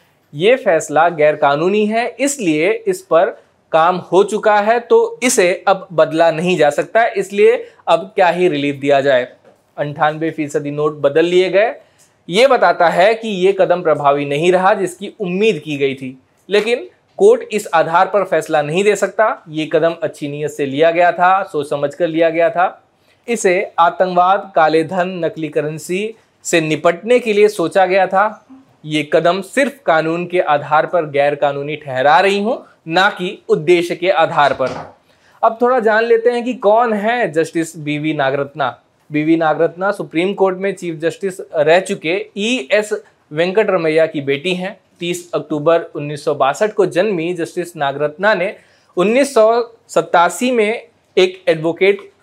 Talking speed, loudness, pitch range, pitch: 160 wpm, -15 LUFS, 155-210 Hz, 175 Hz